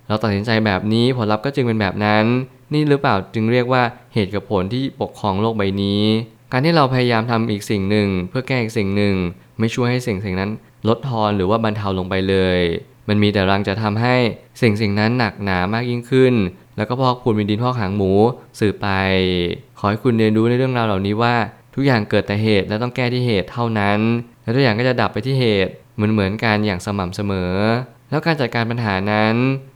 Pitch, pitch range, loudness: 110 Hz, 100-125 Hz, -18 LUFS